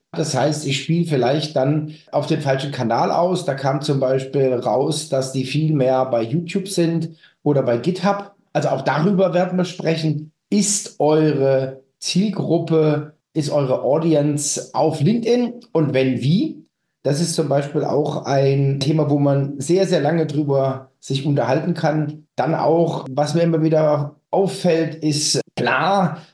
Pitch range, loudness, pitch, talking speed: 140-165 Hz, -19 LUFS, 150 Hz, 155 wpm